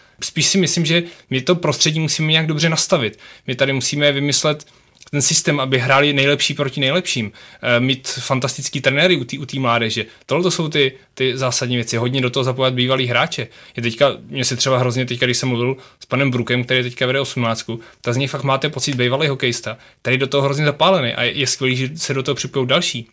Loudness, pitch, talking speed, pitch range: -17 LUFS, 135 Hz, 215 wpm, 125-145 Hz